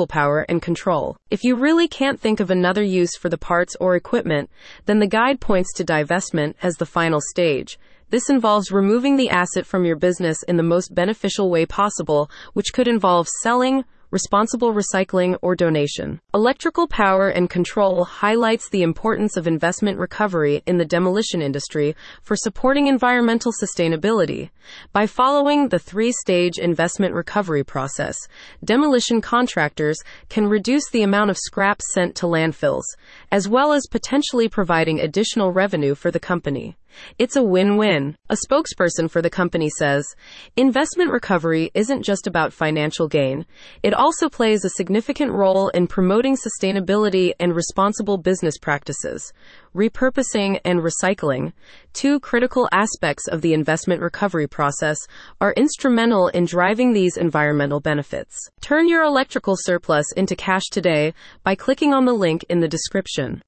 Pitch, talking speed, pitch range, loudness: 190 Hz, 150 wpm, 170-225 Hz, -19 LUFS